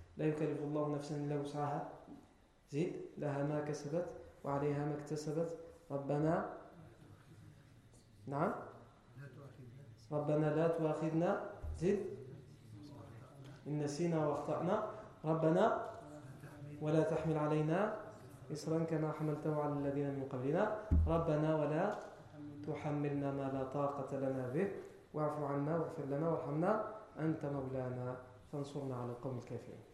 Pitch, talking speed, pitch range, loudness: 145 Hz, 105 wpm, 135-155 Hz, -39 LUFS